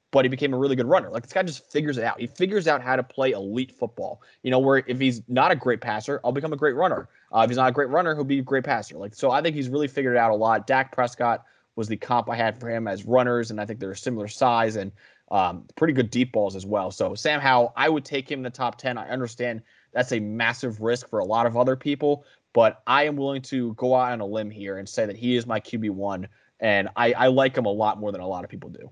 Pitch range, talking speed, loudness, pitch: 115-135 Hz, 290 wpm, -24 LUFS, 125 Hz